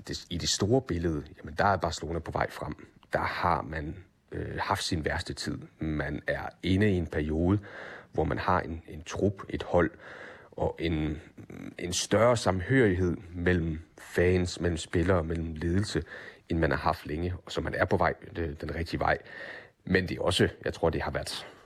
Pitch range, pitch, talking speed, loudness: 80-95 Hz, 85 Hz, 190 wpm, -30 LUFS